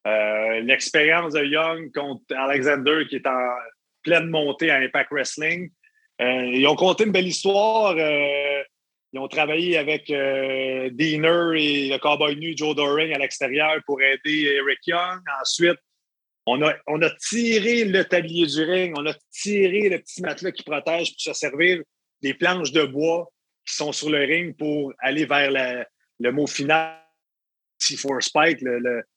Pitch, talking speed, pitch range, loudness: 150 Hz, 165 wpm, 140-170 Hz, -21 LUFS